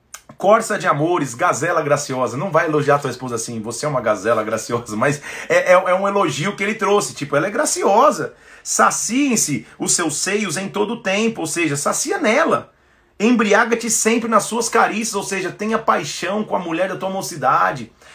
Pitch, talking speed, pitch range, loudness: 190 Hz, 190 wpm, 145-215 Hz, -18 LUFS